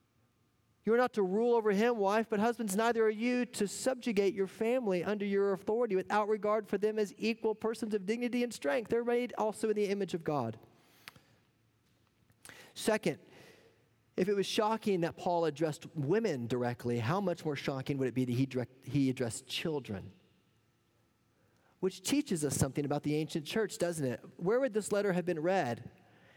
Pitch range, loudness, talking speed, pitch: 130-215 Hz, -33 LUFS, 180 wpm, 185 Hz